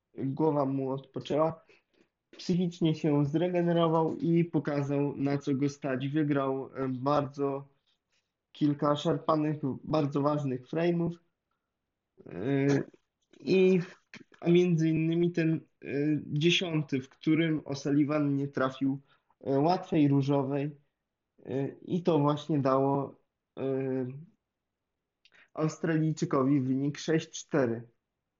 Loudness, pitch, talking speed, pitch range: -29 LUFS, 145 Hz, 80 wpm, 135-160 Hz